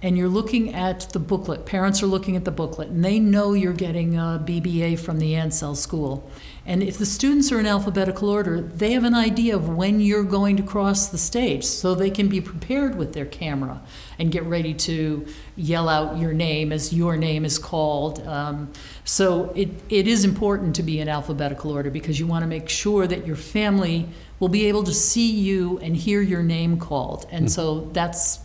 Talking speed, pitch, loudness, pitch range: 205 wpm, 175 Hz, -22 LUFS, 155-200 Hz